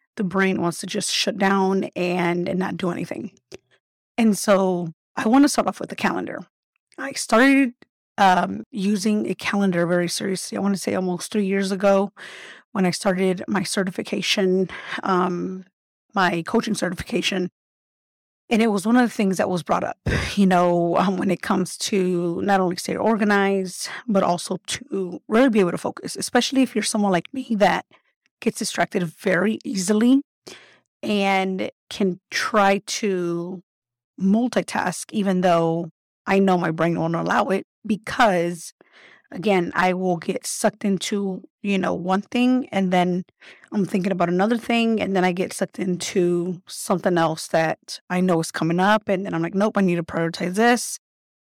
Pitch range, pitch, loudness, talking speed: 180-210 Hz, 195 Hz, -22 LUFS, 170 wpm